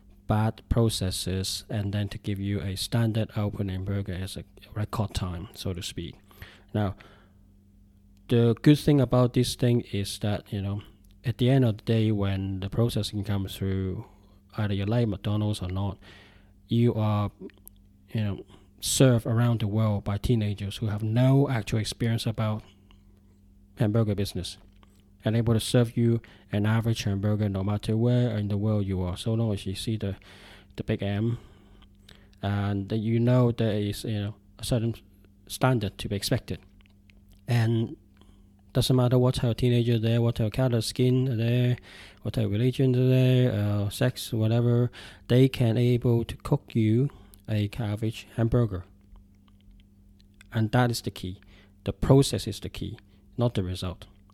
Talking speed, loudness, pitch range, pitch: 160 wpm, -27 LUFS, 100-115 Hz, 105 Hz